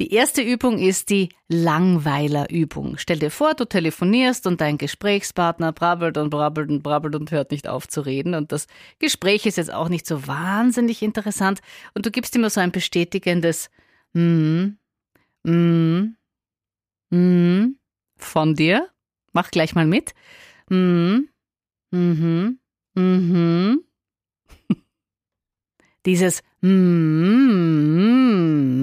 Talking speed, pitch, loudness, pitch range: 125 wpm, 175 Hz, -20 LUFS, 160-205 Hz